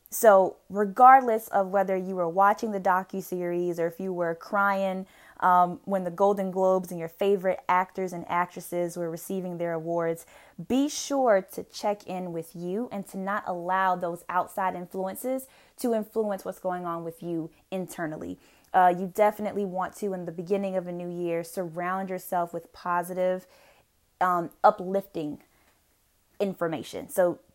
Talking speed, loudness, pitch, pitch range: 155 wpm, -27 LUFS, 185 Hz, 175-200 Hz